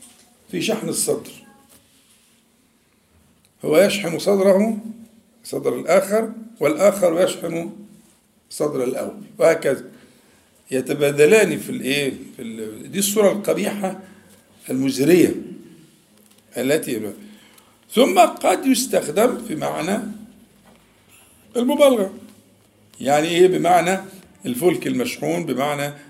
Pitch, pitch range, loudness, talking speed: 195 Hz, 160-225 Hz, -19 LUFS, 80 wpm